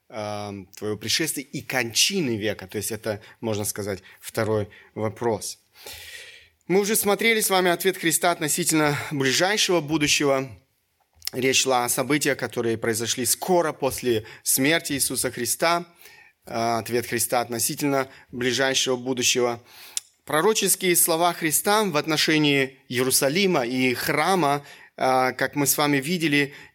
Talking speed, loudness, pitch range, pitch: 115 wpm, -22 LUFS, 120-160 Hz, 135 Hz